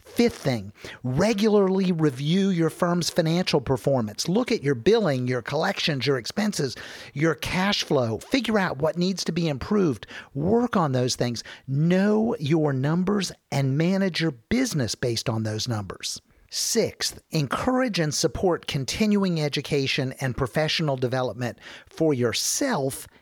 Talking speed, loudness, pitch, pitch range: 135 wpm, -24 LUFS, 155 Hz, 130-190 Hz